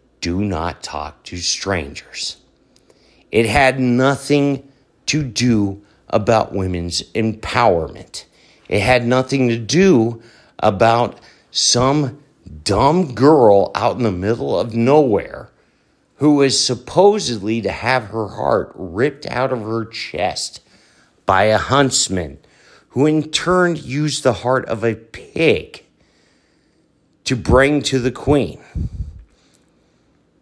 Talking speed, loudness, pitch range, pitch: 110 wpm, -17 LUFS, 105-135 Hz, 120 Hz